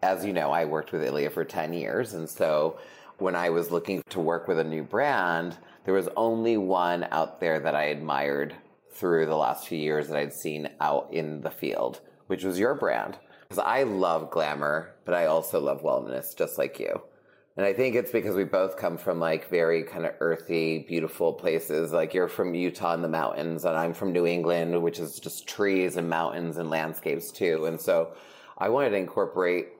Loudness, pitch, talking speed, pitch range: -28 LUFS, 85 Hz, 205 wpm, 80-90 Hz